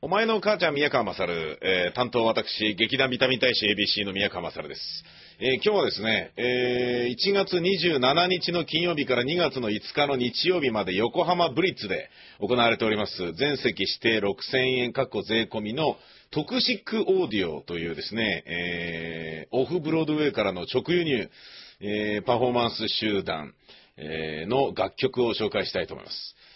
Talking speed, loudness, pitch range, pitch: 325 characters per minute, -25 LUFS, 105-160 Hz, 125 Hz